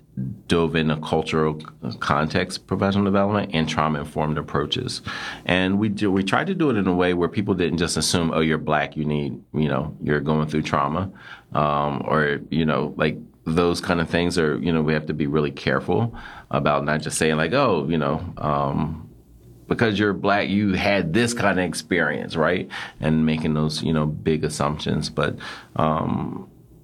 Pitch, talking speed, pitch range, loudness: 80 Hz, 190 wpm, 75-95 Hz, -22 LUFS